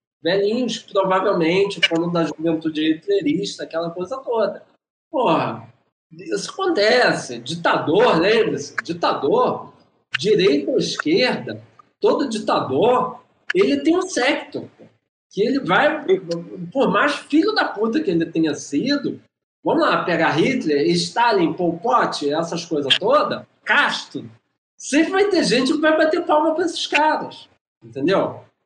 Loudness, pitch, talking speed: -19 LUFS, 240 Hz, 125 wpm